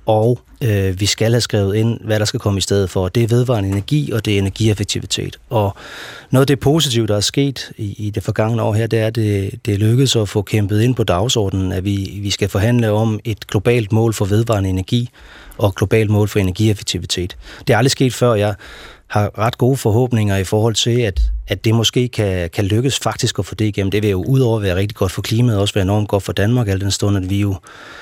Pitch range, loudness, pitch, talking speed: 100-115 Hz, -17 LUFS, 110 Hz, 245 wpm